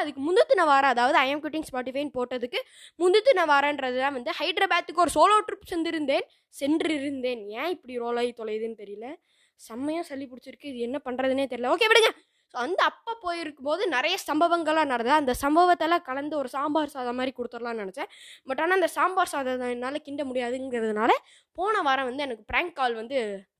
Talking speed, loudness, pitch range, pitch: 165 wpm, -25 LUFS, 255-340 Hz, 285 Hz